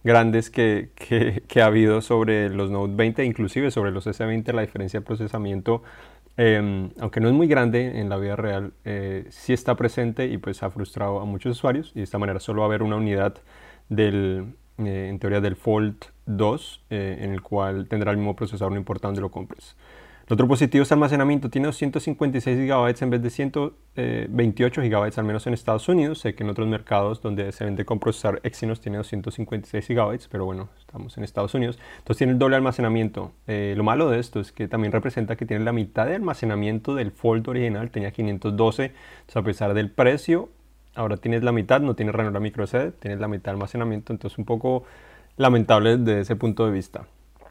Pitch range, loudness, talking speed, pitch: 100-120 Hz, -24 LUFS, 200 wpm, 110 Hz